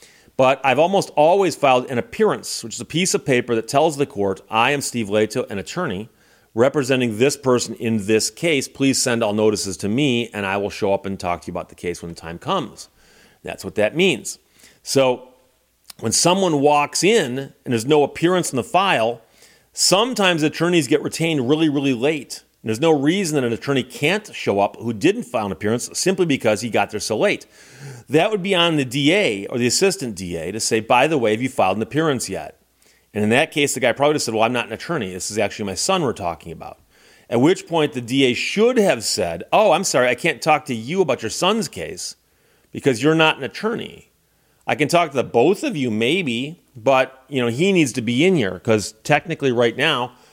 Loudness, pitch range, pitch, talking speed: -19 LUFS, 115-155 Hz, 130 Hz, 220 wpm